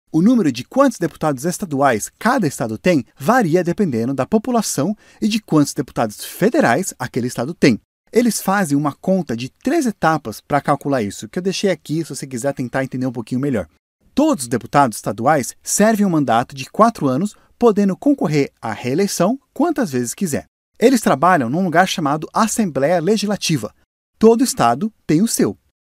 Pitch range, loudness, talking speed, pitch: 135-215 Hz, -18 LUFS, 165 wpm, 175 Hz